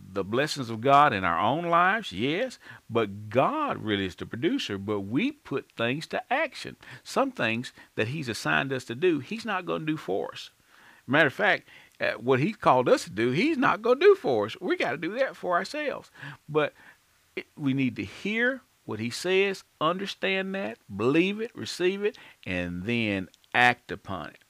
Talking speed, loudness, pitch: 195 wpm, -27 LUFS, 155 Hz